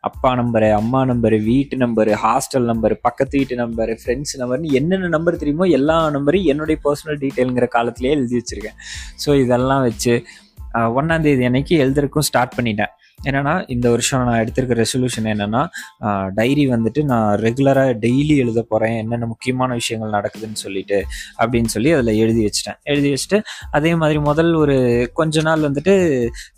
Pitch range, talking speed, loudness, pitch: 115-145 Hz, 150 wpm, -18 LUFS, 125 Hz